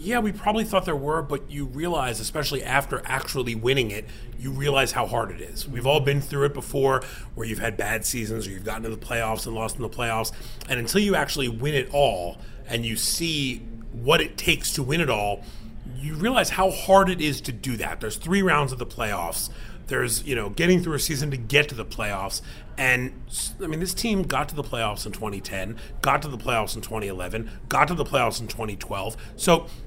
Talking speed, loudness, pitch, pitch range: 220 wpm, -25 LUFS, 125 Hz, 110-145 Hz